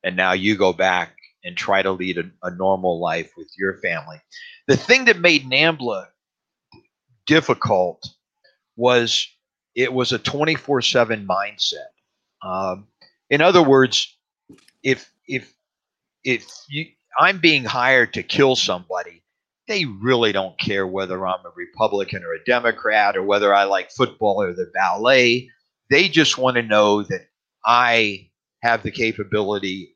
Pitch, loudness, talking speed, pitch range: 120 Hz, -19 LUFS, 140 wpm, 100-140 Hz